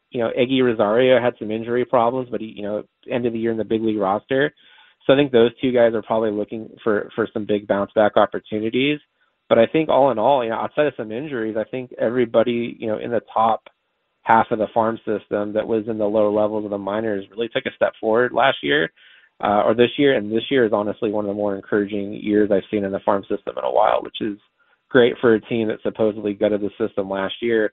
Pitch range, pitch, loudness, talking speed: 105-120 Hz, 110 Hz, -20 LUFS, 245 wpm